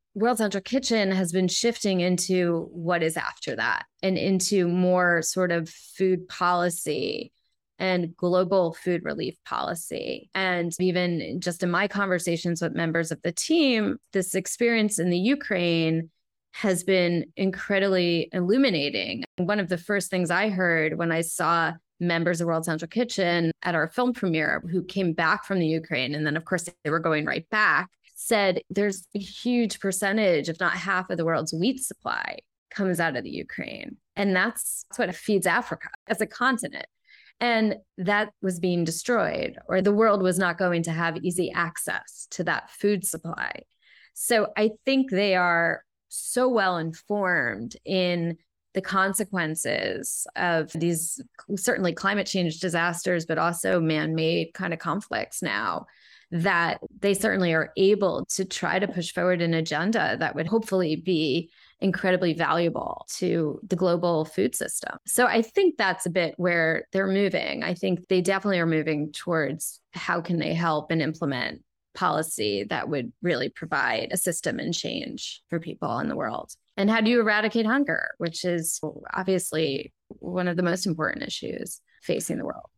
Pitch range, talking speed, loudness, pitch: 170-200 Hz, 160 wpm, -25 LUFS, 180 Hz